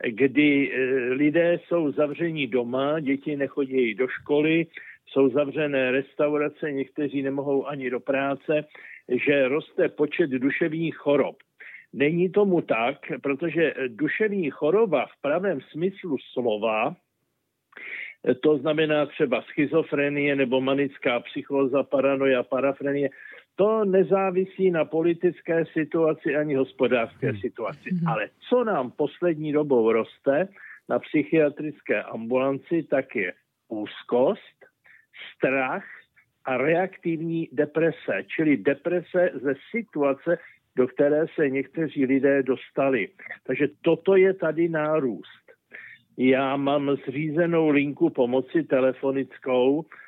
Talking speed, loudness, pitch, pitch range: 105 wpm, -24 LUFS, 150 Hz, 135-165 Hz